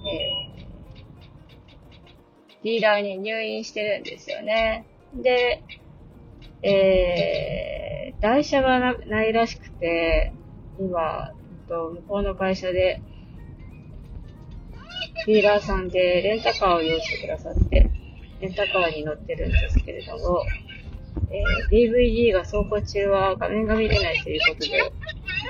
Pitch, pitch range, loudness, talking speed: 200 Hz, 175-220 Hz, -23 LUFS, 230 characters per minute